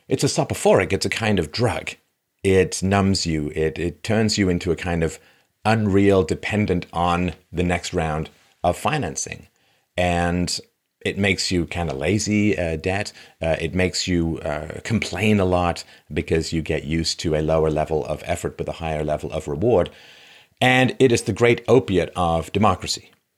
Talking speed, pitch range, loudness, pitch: 175 wpm, 80-100 Hz, -21 LUFS, 90 Hz